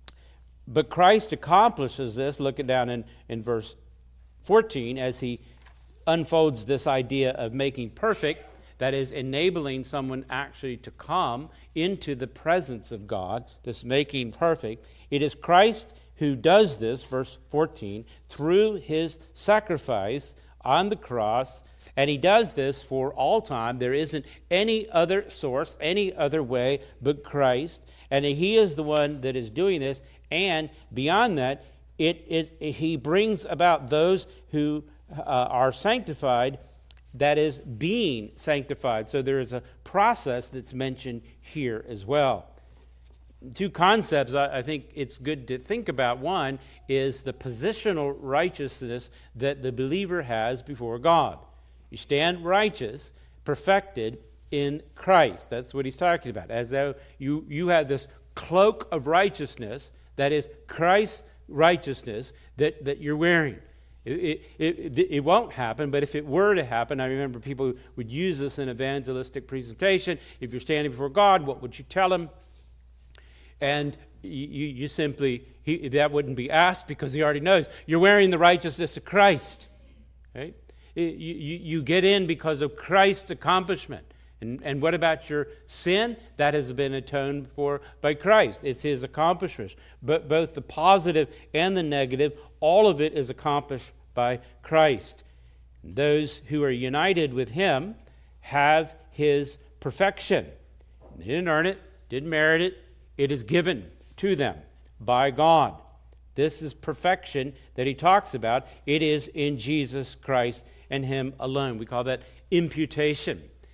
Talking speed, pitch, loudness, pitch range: 150 wpm, 140 Hz, -25 LUFS, 125-160 Hz